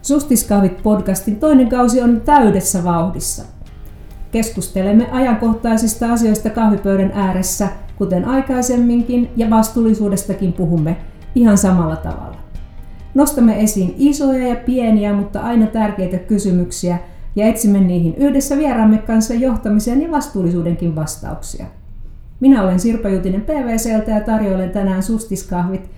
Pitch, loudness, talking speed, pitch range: 210 Hz, -15 LUFS, 110 wpm, 185-235 Hz